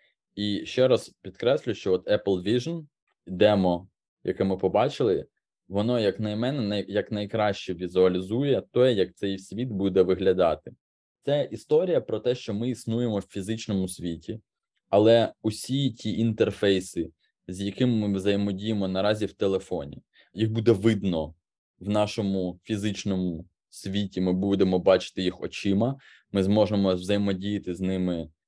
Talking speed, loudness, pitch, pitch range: 130 wpm, -26 LUFS, 100 Hz, 95-115 Hz